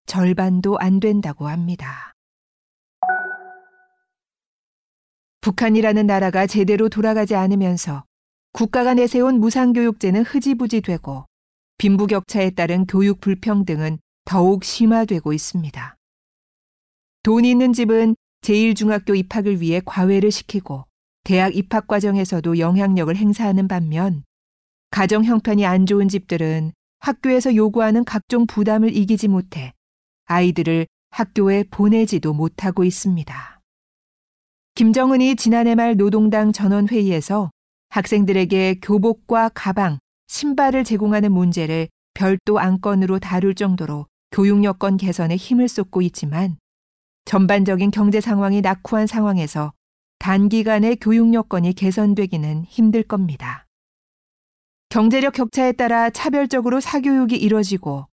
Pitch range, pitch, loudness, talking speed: 185-225 Hz, 200 Hz, -18 LUFS, 285 characters per minute